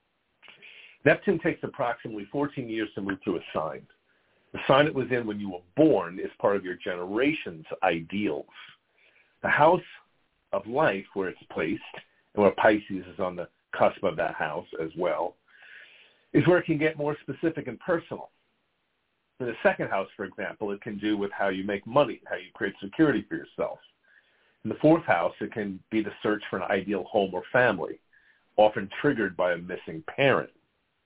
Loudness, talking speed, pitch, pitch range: -27 LUFS, 180 wpm, 110 Hz, 100-150 Hz